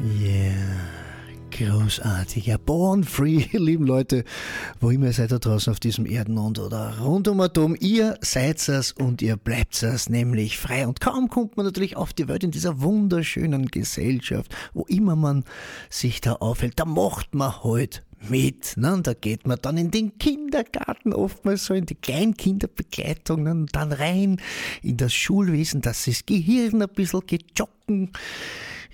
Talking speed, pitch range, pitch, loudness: 165 wpm, 115-190 Hz, 145 Hz, -24 LUFS